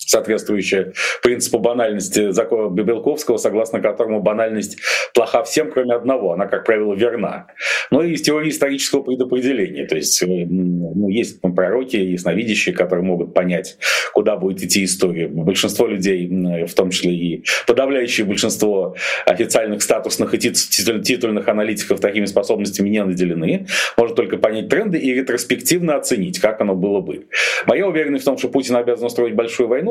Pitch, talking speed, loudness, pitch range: 110 Hz, 155 wpm, -18 LUFS, 95-130 Hz